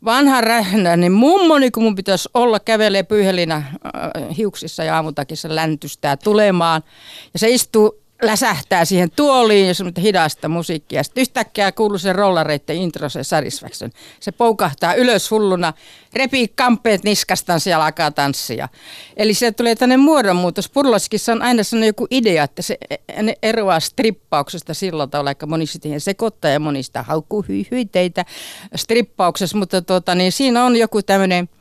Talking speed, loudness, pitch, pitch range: 145 wpm, -16 LUFS, 195 Hz, 165-225 Hz